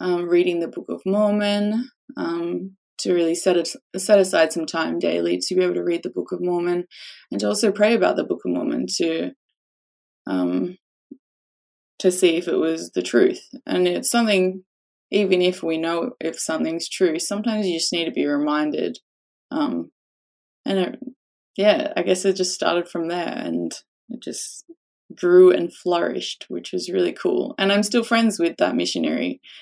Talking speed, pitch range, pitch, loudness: 180 wpm, 165-210 Hz, 180 Hz, -21 LUFS